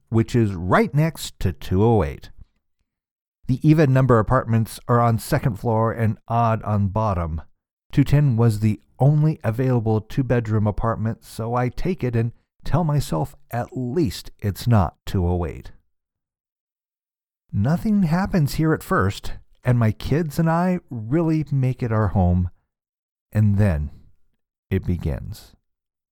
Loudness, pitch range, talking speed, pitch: -21 LUFS, 100-135 Hz, 130 wpm, 115 Hz